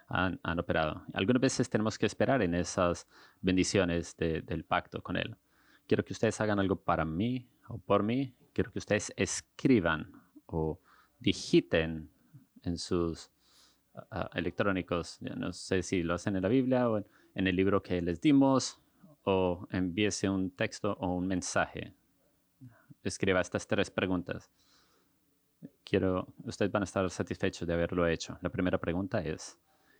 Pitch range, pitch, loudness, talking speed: 90-110 Hz, 95 Hz, -32 LUFS, 150 wpm